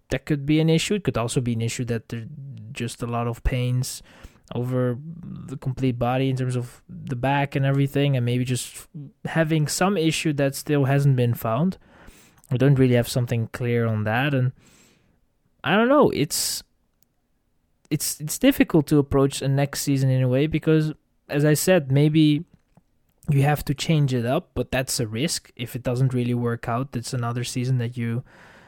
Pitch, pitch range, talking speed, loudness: 135 Hz, 125-150 Hz, 190 wpm, -23 LUFS